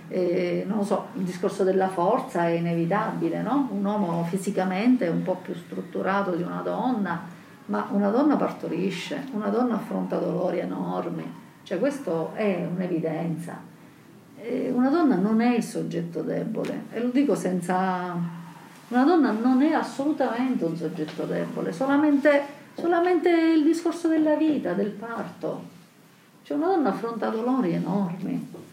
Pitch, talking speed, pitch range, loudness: 210 Hz, 145 wpm, 180-270 Hz, -25 LUFS